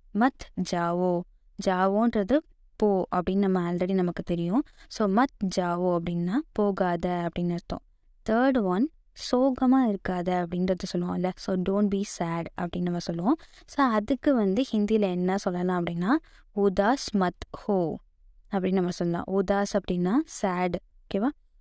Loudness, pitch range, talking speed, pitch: -27 LUFS, 180-220 Hz, 130 wpm, 190 Hz